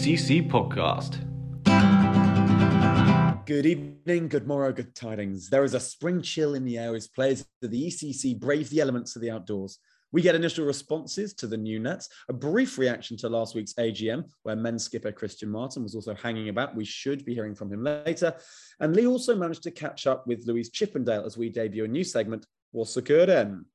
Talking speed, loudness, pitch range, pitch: 190 wpm, -26 LUFS, 110-150 Hz, 130 Hz